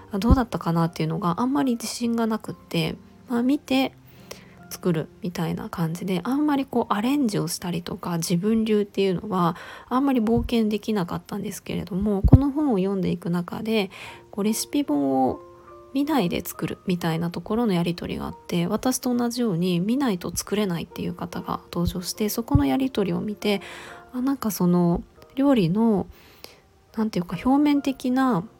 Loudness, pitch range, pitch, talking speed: -24 LUFS, 175-245 Hz, 210 Hz, 375 characters per minute